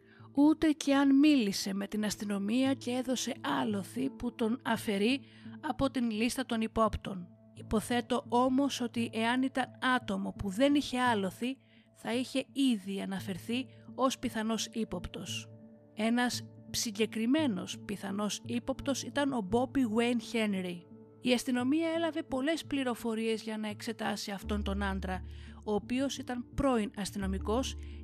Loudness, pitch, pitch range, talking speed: -32 LUFS, 230 Hz, 200-255 Hz, 130 wpm